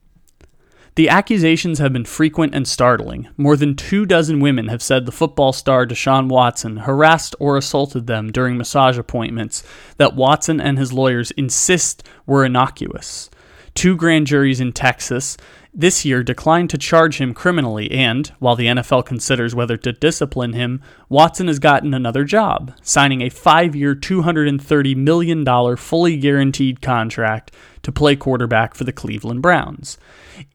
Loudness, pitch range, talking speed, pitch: -16 LUFS, 125-155 Hz, 150 wpm, 135 Hz